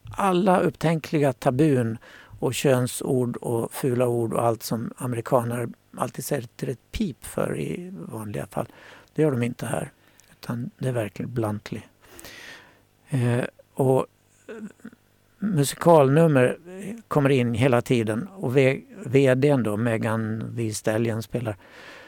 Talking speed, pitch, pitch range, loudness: 120 wpm, 125 Hz, 115-145 Hz, -24 LUFS